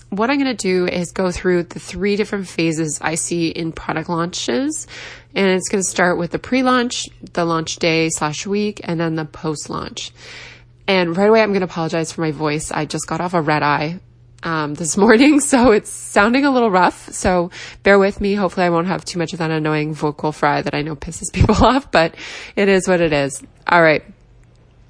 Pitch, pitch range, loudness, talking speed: 175 Hz, 160-200 Hz, -17 LUFS, 220 wpm